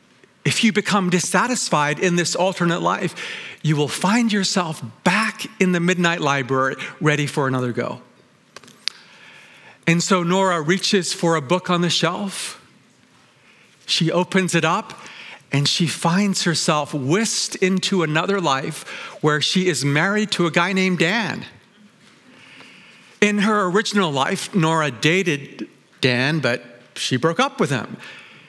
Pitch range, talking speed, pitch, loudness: 150-195 Hz, 135 wpm, 175 Hz, -20 LUFS